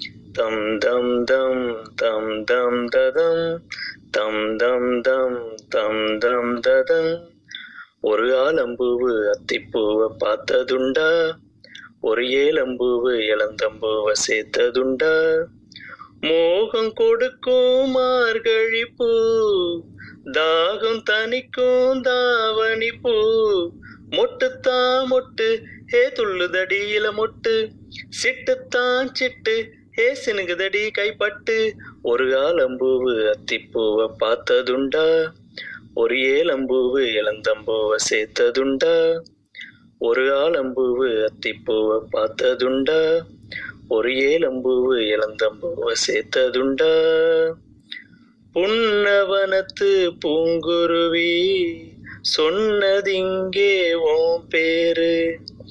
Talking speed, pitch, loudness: 60 wpm, 255 Hz, -20 LUFS